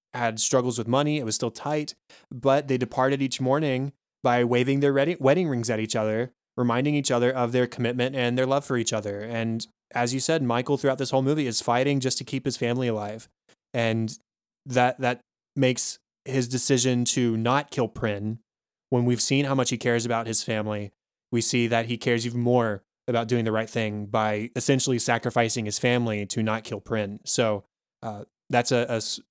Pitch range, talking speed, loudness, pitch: 115-130 Hz, 195 wpm, -25 LUFS, 120 Hz